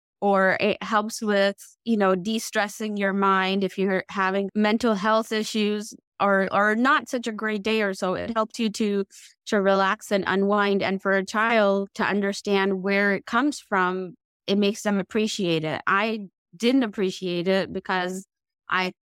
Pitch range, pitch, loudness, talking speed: 190-220 Hz, 200 Hz, -24 LUFS, 170 wpm